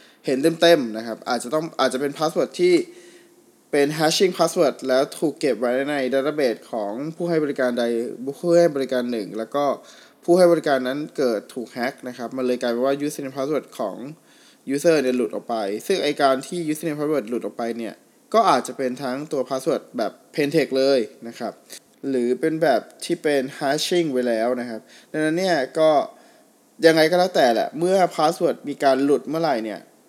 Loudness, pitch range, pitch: -22 LUFS, 130-170 Hz, 145 Hz